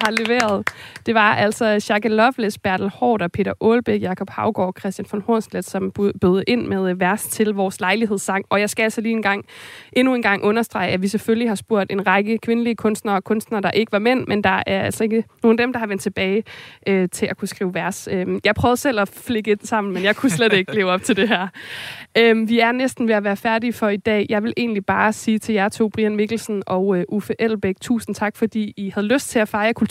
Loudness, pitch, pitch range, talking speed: -19 LUFS, 210 Hz, 195-225 Hz, 240 wpm